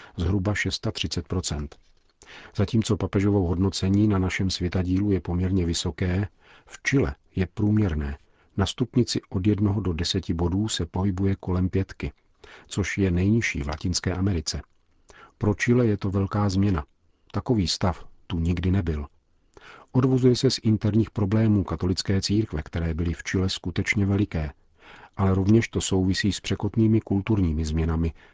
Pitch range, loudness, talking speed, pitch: 85-105 Hz, -25 LUFS, 135 wpm, 95 Hz